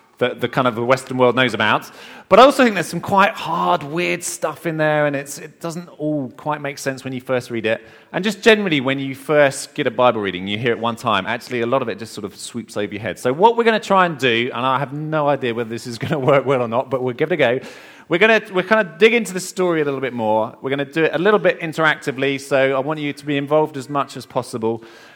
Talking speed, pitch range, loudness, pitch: 280 wpm, 125-165 Hz, -18 LUFS, 140 Hz